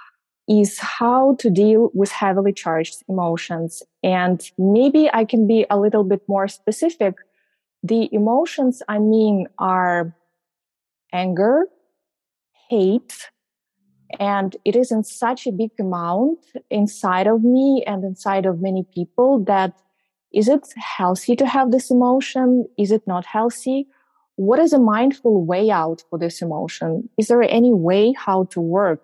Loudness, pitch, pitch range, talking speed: -18 LUFS, 210 Hz, 185-245 Hz, 145 wpm